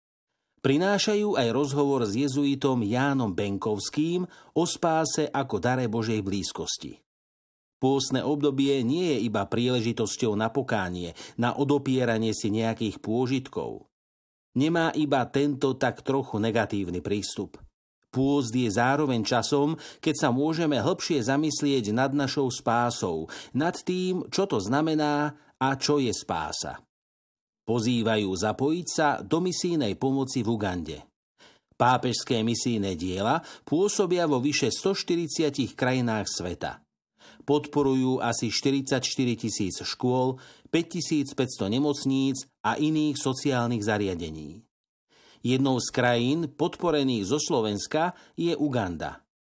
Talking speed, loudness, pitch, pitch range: 110 wpm, -26 LUFS, 135 Hz, 115-145 Hz